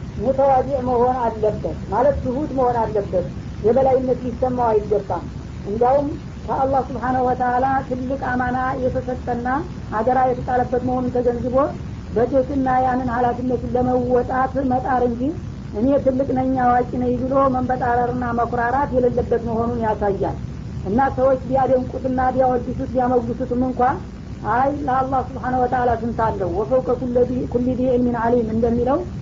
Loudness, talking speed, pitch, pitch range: -20 LUFS, 110 wpm, 250 Hz, 245-260 Hz